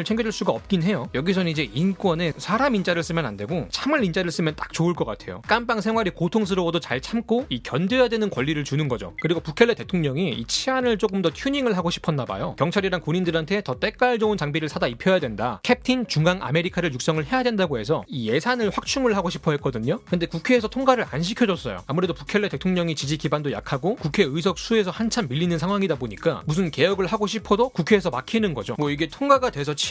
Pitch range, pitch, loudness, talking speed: 160-220 Hz, 180 Hz, -23 LUFS, 470 characters per minute